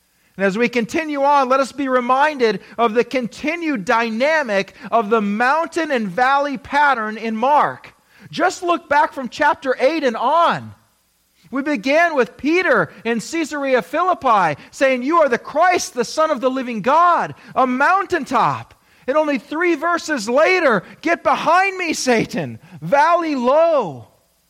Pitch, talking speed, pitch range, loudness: 275 Hz, 145 wpm, 235-315 Hz, -17 LUFS